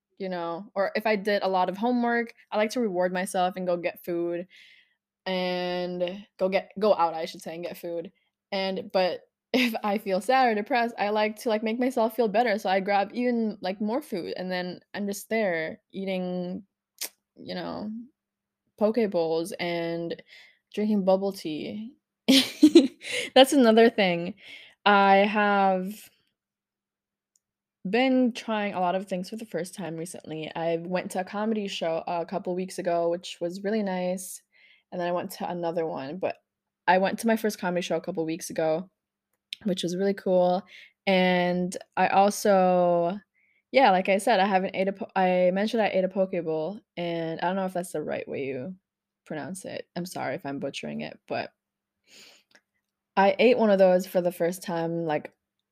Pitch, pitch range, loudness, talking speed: 190 Hz, 175-215 Hz, -26 LUFS, 180 wpm